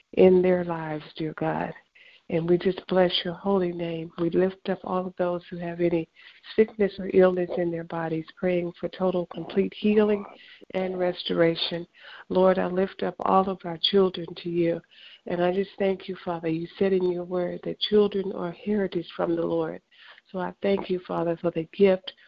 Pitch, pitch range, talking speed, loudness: 180 Hz, 170-190 Hz, 190 wpm, -26 LUFS